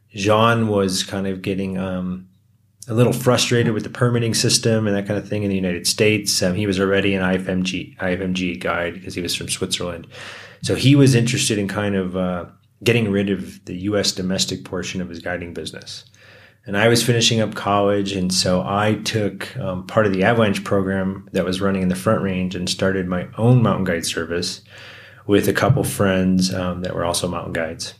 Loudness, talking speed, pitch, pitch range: -19 LUFS, 200 wpm, 100 Hz, 95-110 Hz